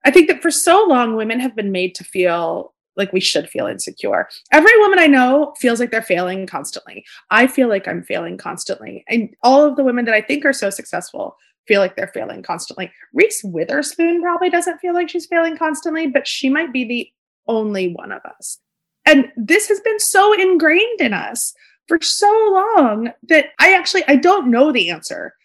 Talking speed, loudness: 200 wpm, -15 LUFS